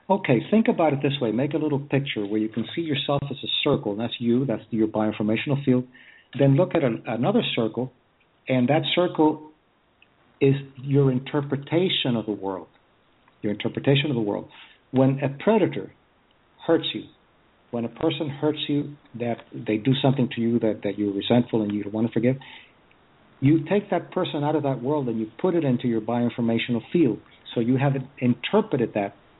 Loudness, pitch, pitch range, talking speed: -24 LUFS, 130 Hz, 115-150 Hz, 190 wpm